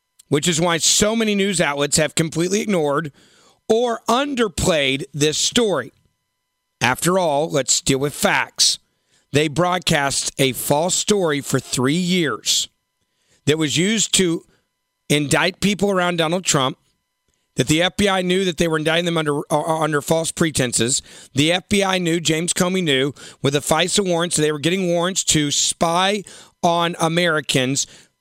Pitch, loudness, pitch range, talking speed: 165 Hz, -18 LUFS, 145-180 Hz, 145 wpm